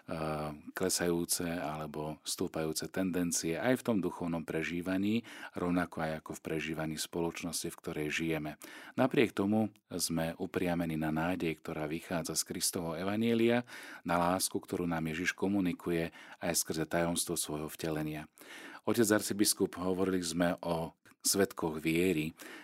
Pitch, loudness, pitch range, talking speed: 85 Hz, -34 LUFS, 80-95 Hz, 125 wpm